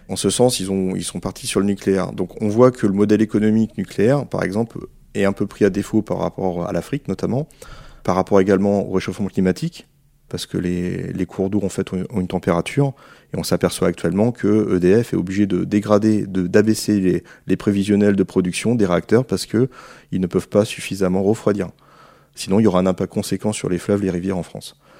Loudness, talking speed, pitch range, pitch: -19 LUFS, 220 wpm, 95-105 Hz, 100 Hz